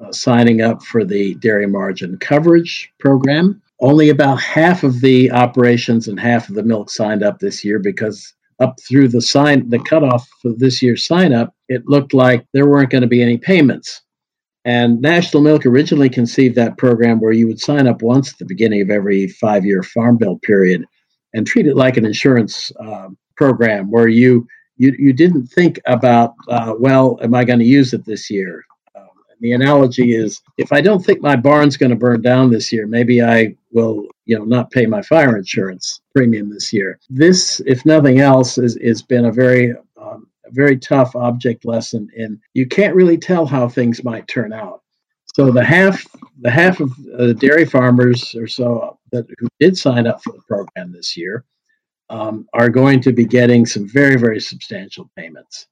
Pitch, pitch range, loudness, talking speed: 125 Hz, 115-140 Hz, -13 LUFS, 190 wpm